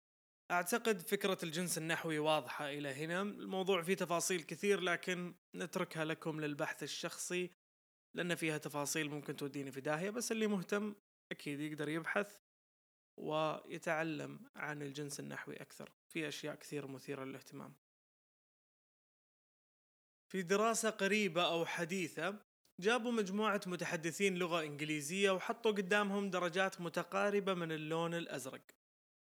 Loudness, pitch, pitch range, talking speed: -39 LUFS, 170 Hz, 155-195 Hz, 115 wpm